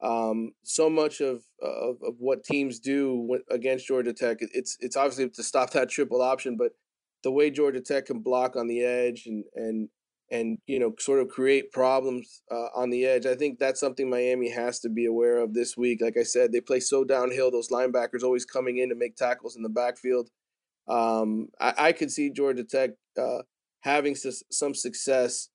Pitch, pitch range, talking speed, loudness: 125 Hz, 120-135 Hz, 200 wpm, -27 LUFS